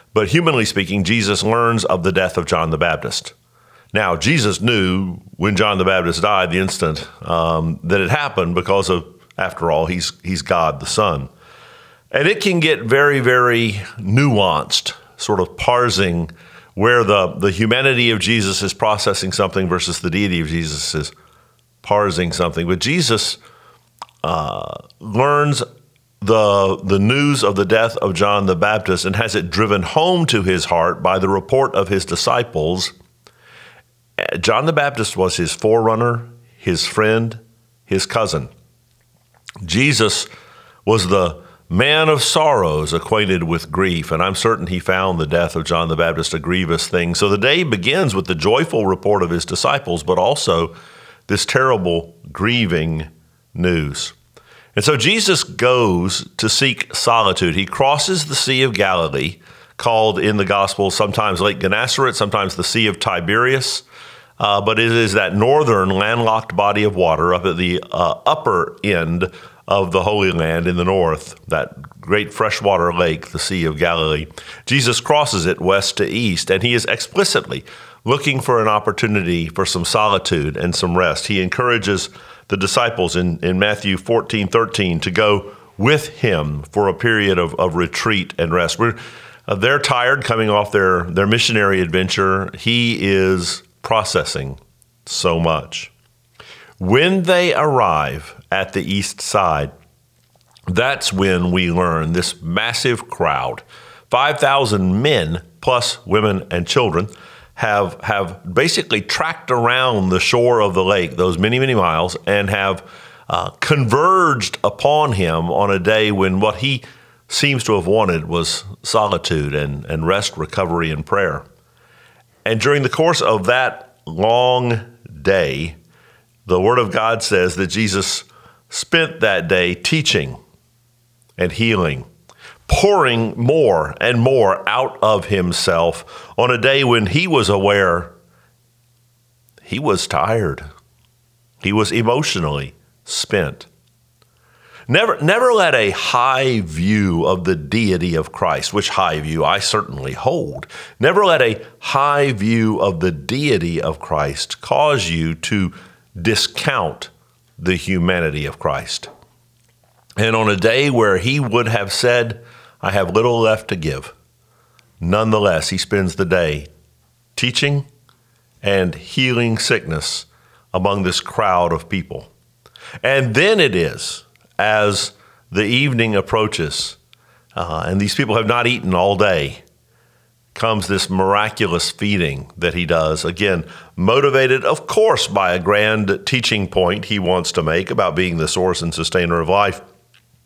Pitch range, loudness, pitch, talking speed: 90-120 Hz, -17 LUFS, 100 Hz, 145 wpm